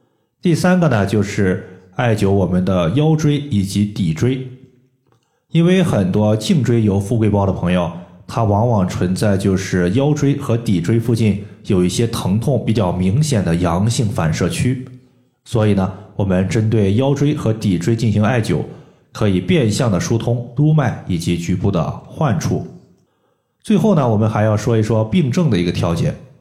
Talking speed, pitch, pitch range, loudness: 245 characters per minute, 110 Hz, 95-130 Hz, -17 LUFS